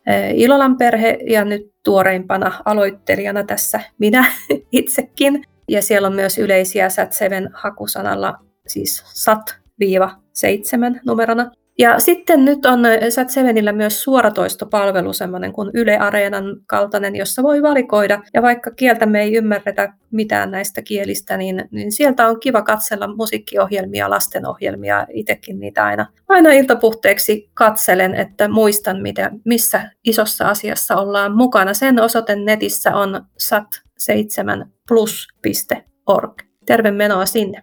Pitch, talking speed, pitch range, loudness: 210 Hz, 120 wpm, 200-235 Hz, -15 LUFS